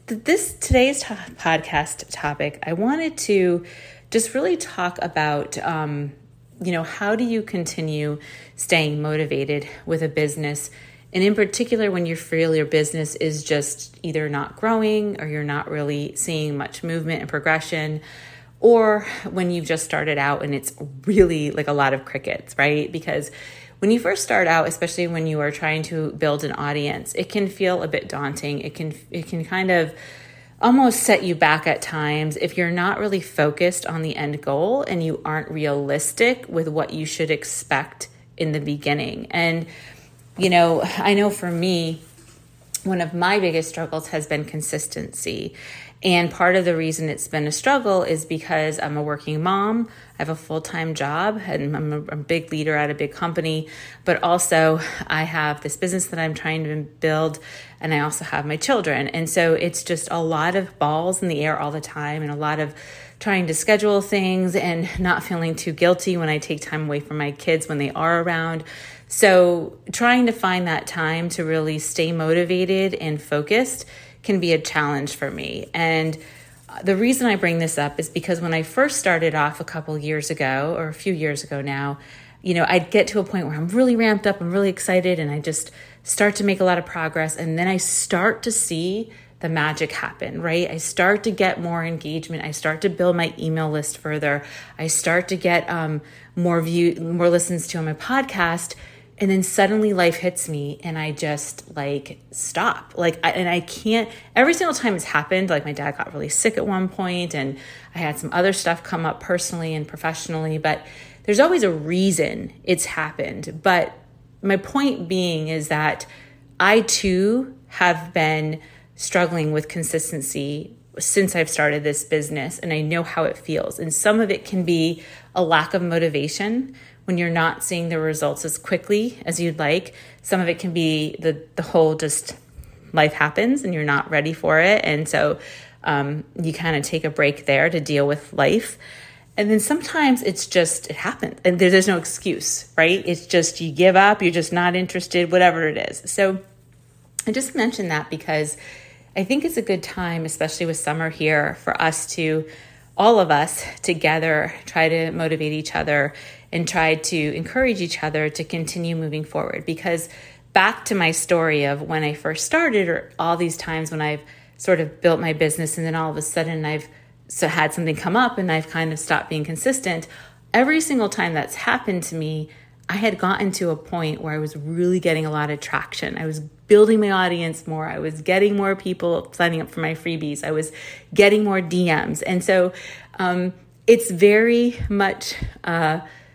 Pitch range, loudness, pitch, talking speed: 155-185 Hz, -21 LUFS, 165 Hz, 190 wpm